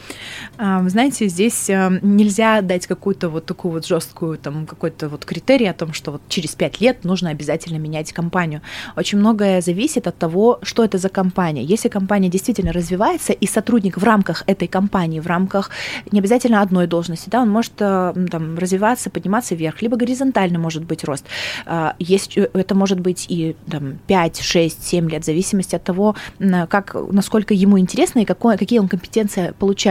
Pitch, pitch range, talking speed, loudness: 190 Hz, 170-210 Hz, 170 wpm, -18 LUFS